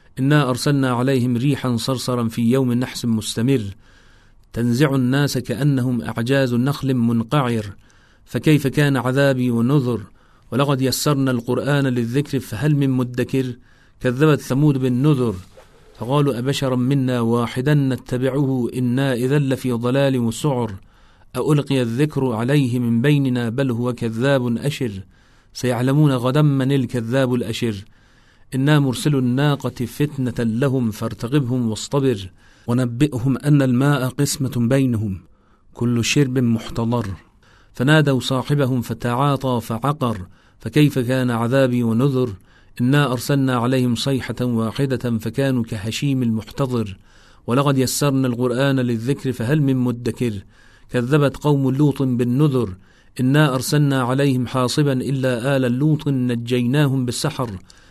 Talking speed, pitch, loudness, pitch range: 110 wpm, 125 Hz, -19 LUFS, 115-135 Hz